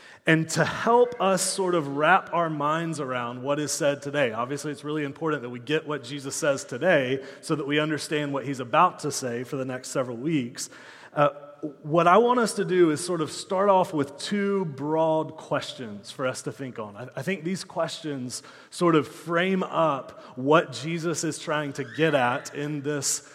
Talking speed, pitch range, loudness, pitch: 200 wpm, 140-170 Hz, -25 LUFS, 150 Hz